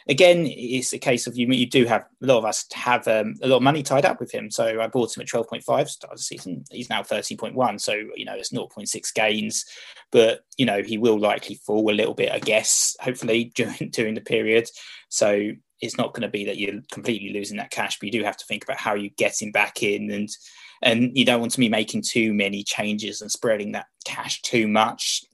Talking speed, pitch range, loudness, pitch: 245 wpm, 105-125 Hz, -23 LUFS, 110 Hz